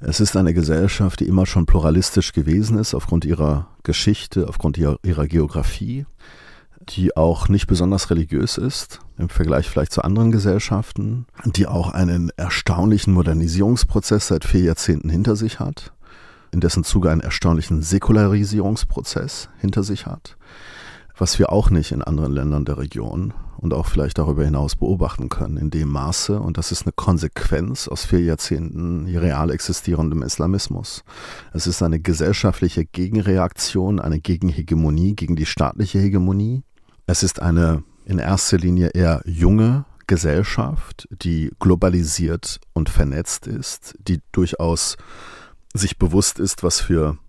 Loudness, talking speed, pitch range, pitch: -20 LUFS, 140 wpm, 80-100 Hz, 90 Hz